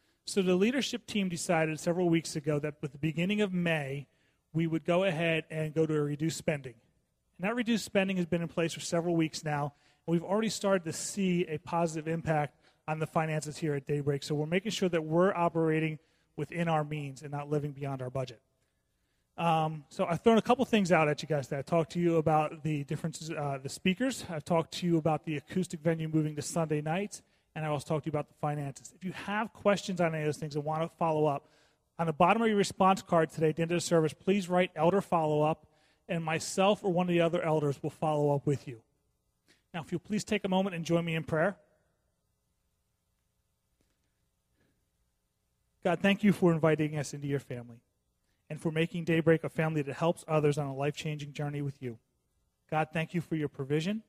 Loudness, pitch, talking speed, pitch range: -31 LUFS, 160 Hz, 220 wpm, 150-175 Hz